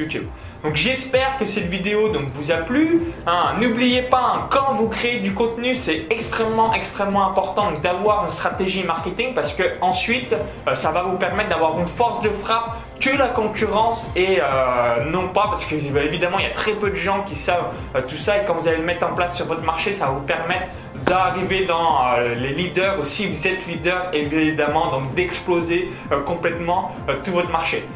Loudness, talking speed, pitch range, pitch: -20 LUFS, 210 wpm, 165-215 Hz, 180 Hz